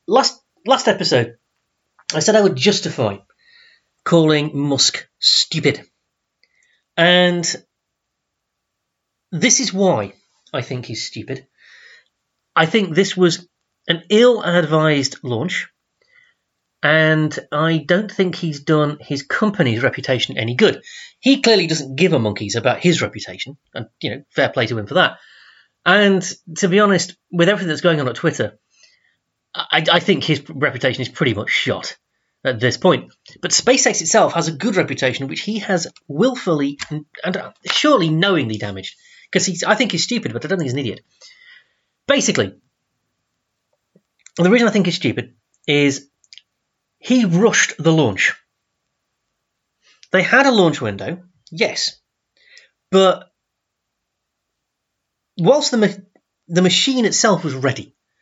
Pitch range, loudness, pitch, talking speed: 145-210 Hz, -17 LUFS, 175 Hz, 135 wpm